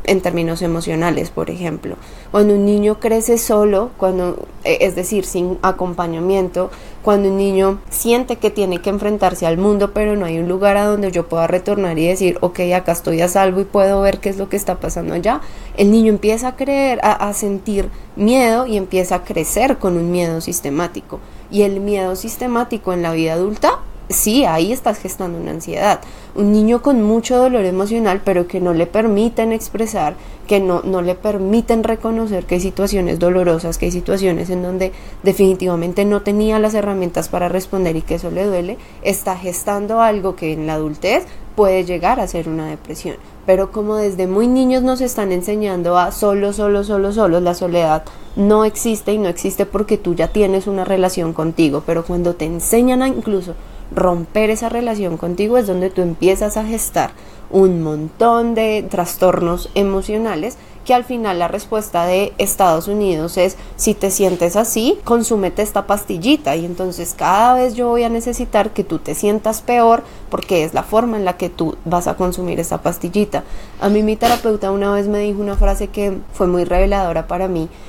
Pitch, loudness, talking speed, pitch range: 195 Hz, -16 LUFS, 185 wpm, 180-215 Hz